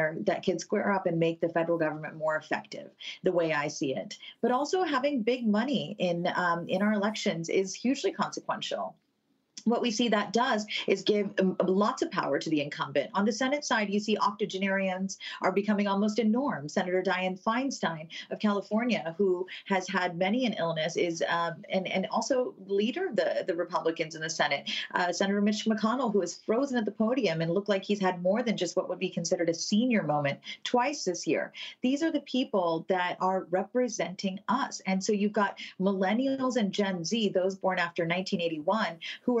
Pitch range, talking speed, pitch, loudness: 180-220 Hz, 195 wpm, 195 Hz, -29 LUFS